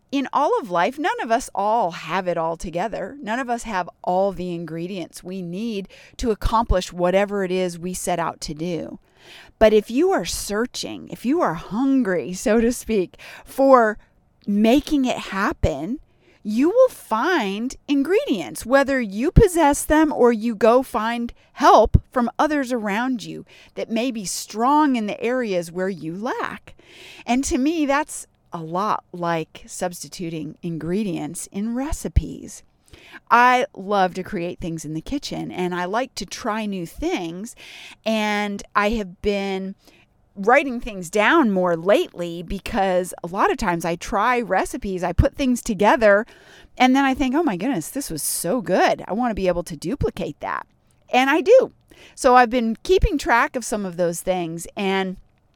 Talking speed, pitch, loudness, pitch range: 165 wpm, 210 Hz, -21 LUFS, 180-255 Hz